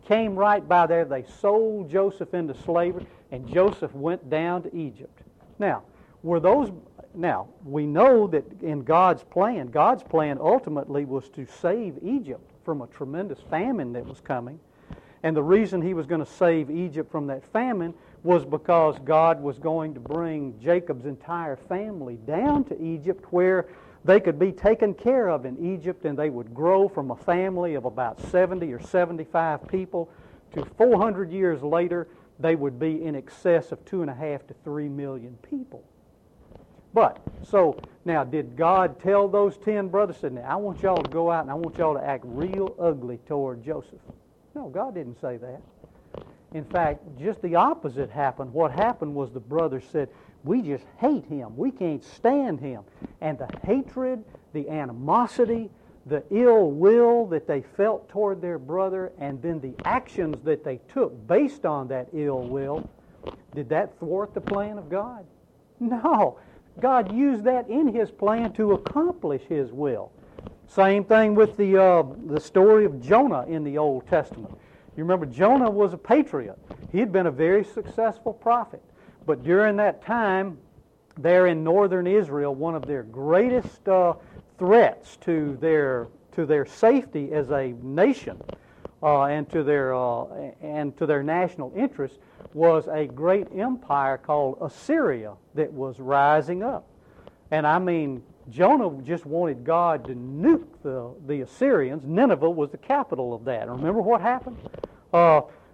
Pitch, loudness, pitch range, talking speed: 165 Hz, -24 LUFS, 145-200 Hz, 165 wpm